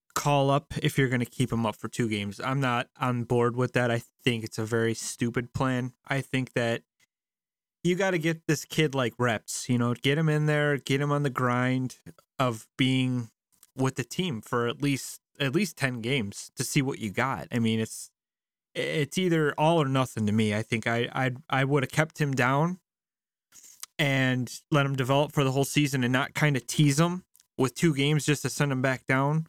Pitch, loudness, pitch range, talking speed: 130 Hz, -27 LUFS, 120-145 Hz, 220 wpm